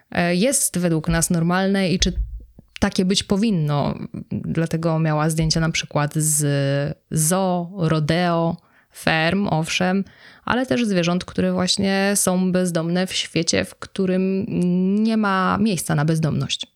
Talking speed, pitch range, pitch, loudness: 125 wpm, 160-190 Hz, 175 Hz, -20 LUFS